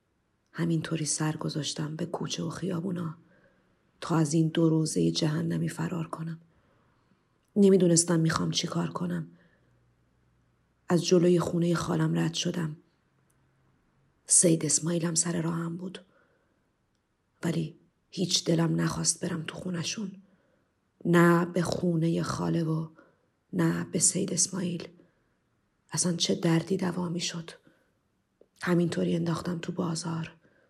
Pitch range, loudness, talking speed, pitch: 165-175 Hz, -28 LUFS, 110 wpm, 170 Hz